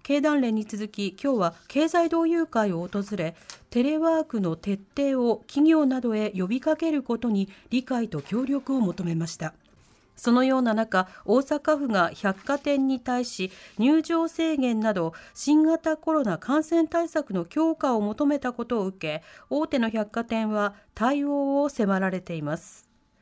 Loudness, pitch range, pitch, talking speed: -25 LUFS, 200-290 Hz, 240 Hz, 285 characters per minute